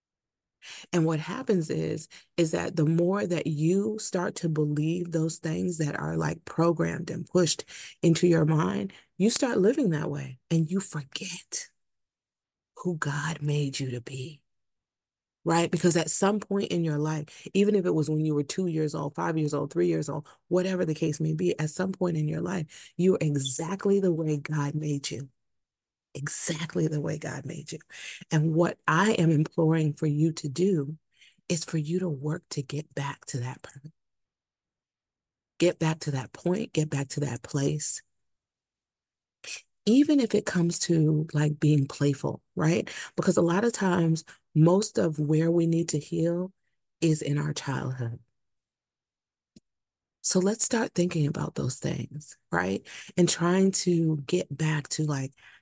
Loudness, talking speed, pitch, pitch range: -26 LUFS, 170 wpm, 160 Hz, 150-175 Hz